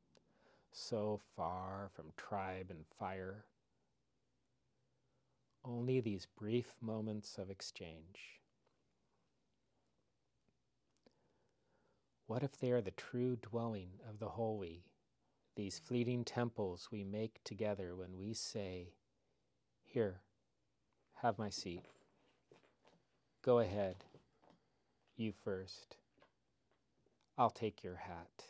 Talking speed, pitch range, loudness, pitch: 90 wpm, 95-115 Hz, -43 LUFS, 105 Hz